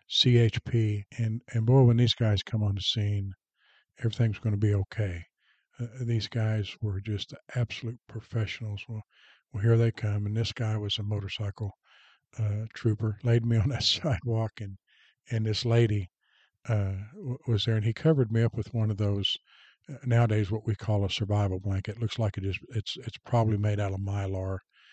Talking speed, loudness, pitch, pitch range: 185 wpm, -29 LUFS, 110 Hz, 105-115 Hz